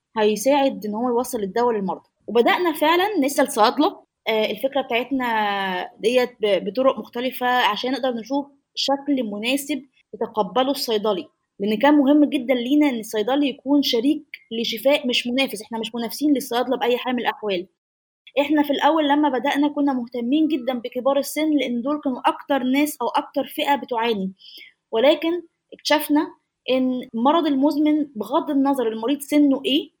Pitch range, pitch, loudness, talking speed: 235-290 Hz, 265 Hz, -21 LUFS, 140 wpm